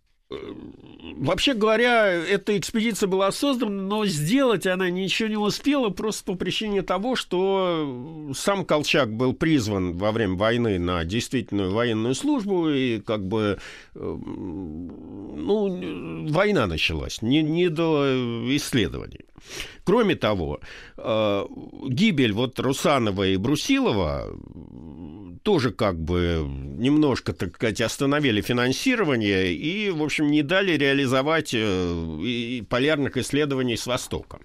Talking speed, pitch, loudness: 110 wpm, 140 Hz, -23 LUFS